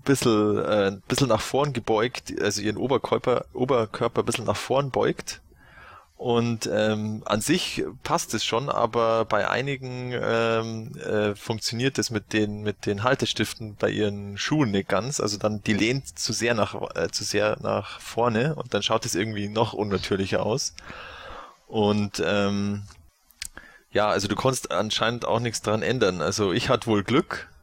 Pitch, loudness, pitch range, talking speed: 110 Hz, -25 LUFS, 105-120 Hz, 160 wpm